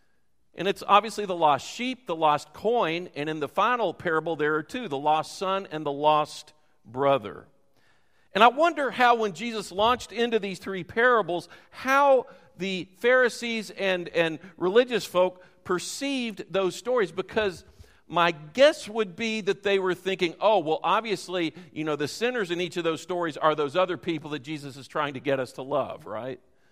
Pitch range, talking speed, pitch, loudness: 155-220 Hz, 180 wpm, 180 Hz, -26 LUFS